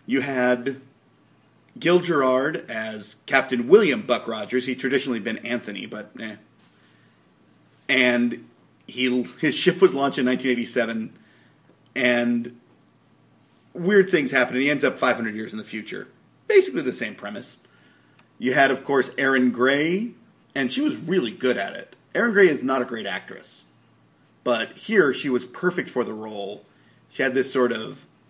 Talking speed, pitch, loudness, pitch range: 155 wpm, 125 Hz, -22 LUFS, 115-135 Hz